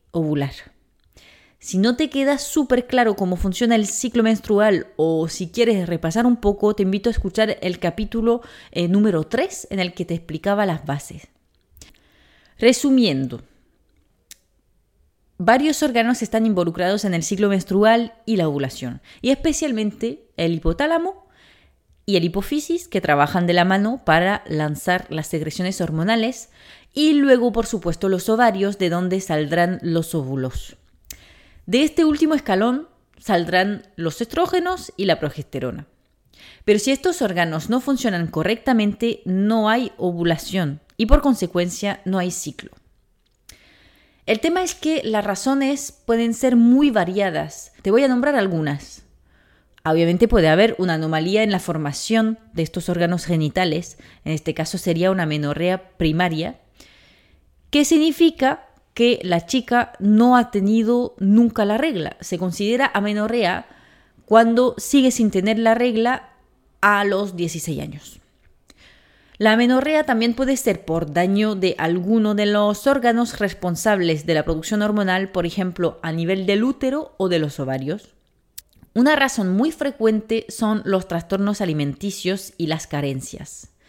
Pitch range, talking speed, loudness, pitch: 170-235 Hz, 140 wpm, -20 LUFS, 200 Hz